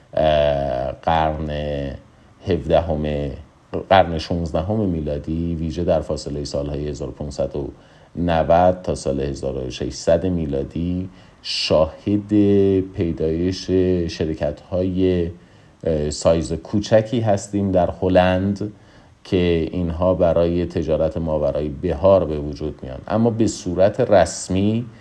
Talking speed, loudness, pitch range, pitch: 90 wpm, -20 LUFS, 75-95 Hz, 85 Hz